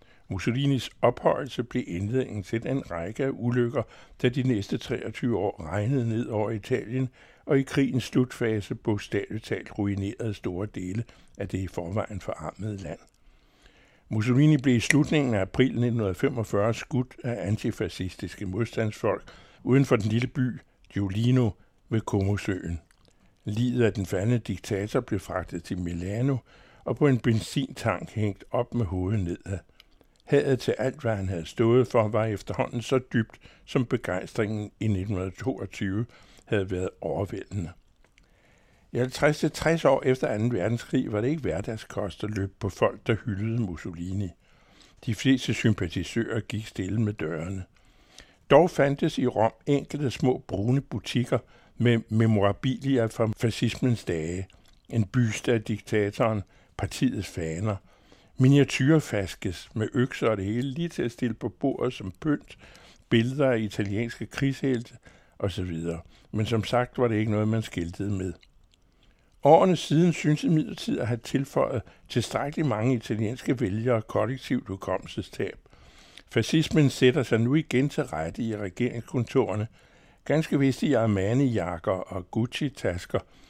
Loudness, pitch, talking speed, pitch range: -27 LUFS, 115 Hz, 135 wpm, 100-130 Hz